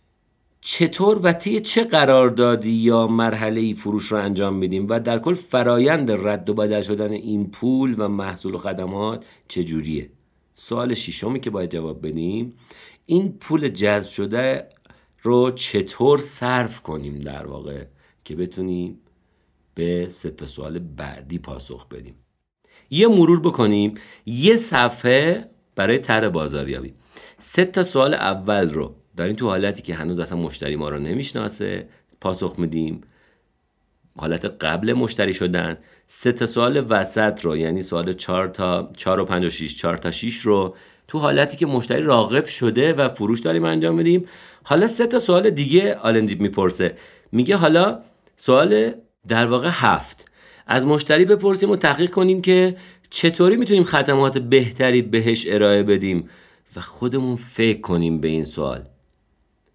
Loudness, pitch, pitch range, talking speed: -20 LUFS, 105 Hz, 85-130 Hz, 145 wpm